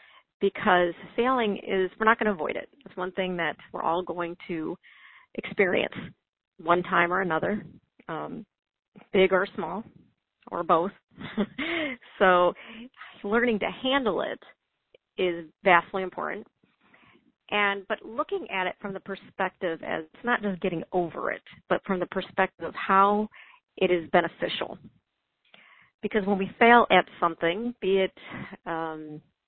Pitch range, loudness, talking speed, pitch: 180-220 Hz, -26 LUFS, 140 wpm, 195 Hz